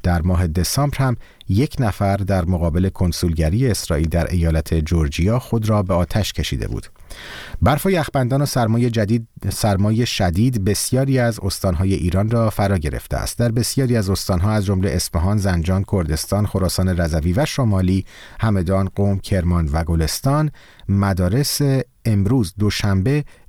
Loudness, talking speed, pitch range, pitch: -19 LUFS, 140 wpm, 90-120 Hz, 100 Hz